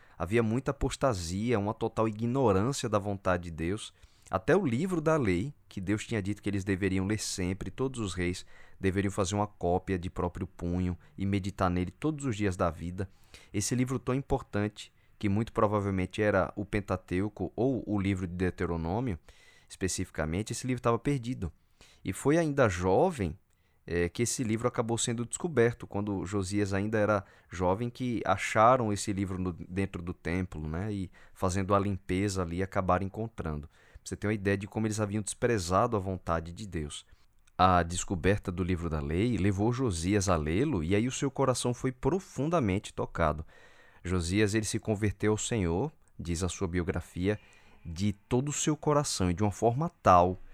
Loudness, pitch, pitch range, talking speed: -31 LUFS, 100 Hz, 90-115 Hz, 175 wpm